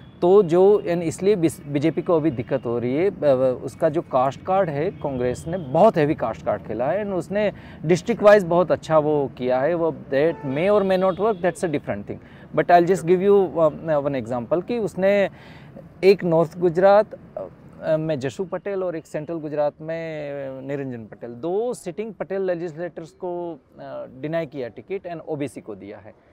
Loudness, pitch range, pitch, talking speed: -21 LUFS, 145-190 Hz, 170 Hz, 180 wpm